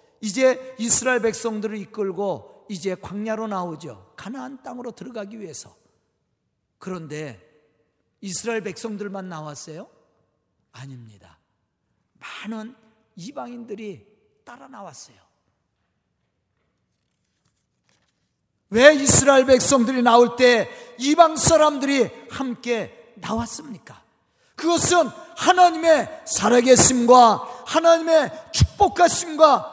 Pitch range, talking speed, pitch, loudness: 185-260 Hz, 225 characters per minute, 225 Hz, -17 LUFS